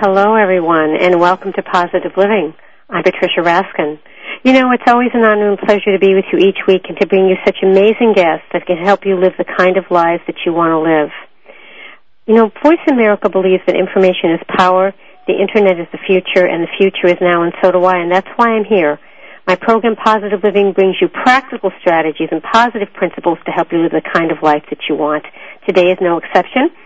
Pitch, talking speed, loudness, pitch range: 190 Hz, 220 wpm, -12 LUFS, 175-210 Hz